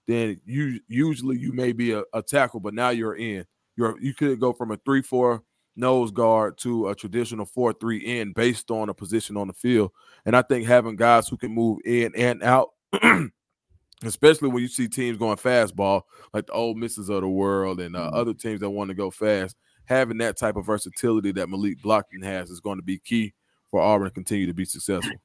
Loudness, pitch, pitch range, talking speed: -24 LUFS, 115 Hz, 100-120 Hz, 215 wpm